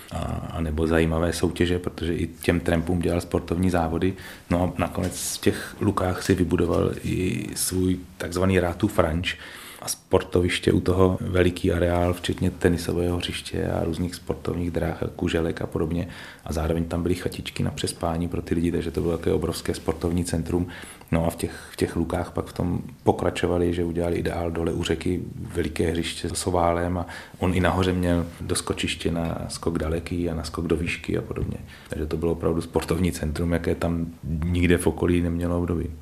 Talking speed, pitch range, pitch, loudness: 180 wpm, 85-90 Hz, 85 Hz, -25 LUFS